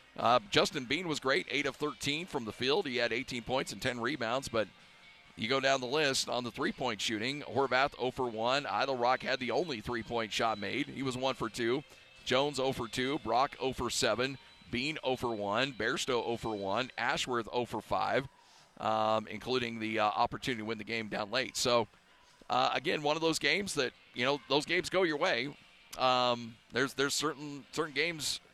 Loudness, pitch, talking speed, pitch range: -33 LUFS, 130 Hz, 205 wpm, 115-140 Hz